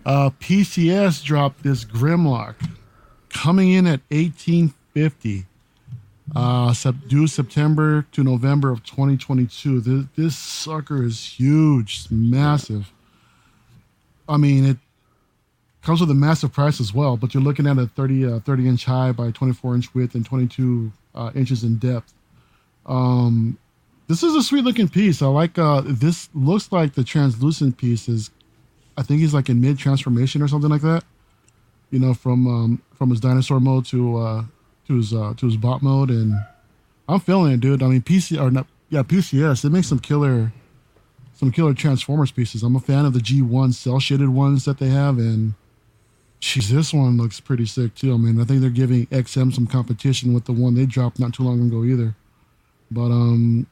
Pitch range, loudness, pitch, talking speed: 120-145 Hz, -19 LUFS, 130 Hz, 175 wpm